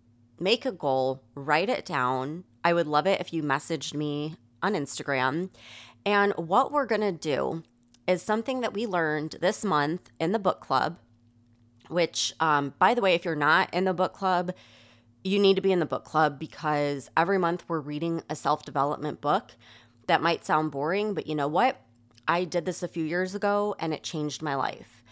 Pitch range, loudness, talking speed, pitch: 140-185 Hz, -27 LUFS, 195 wpm, 160 Hz